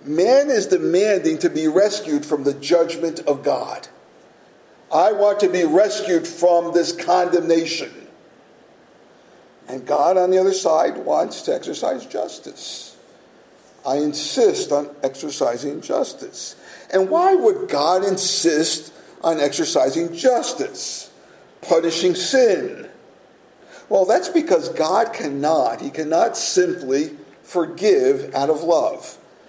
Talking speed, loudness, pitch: 115 wpm, -19 LUFS, 180 Hz